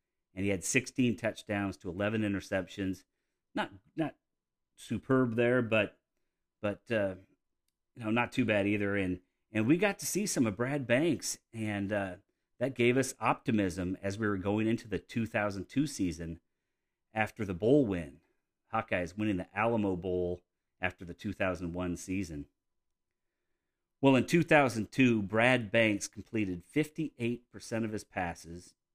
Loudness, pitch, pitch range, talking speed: -32 LUFS, 105 Hz, 95-120 Hz, 140 wpm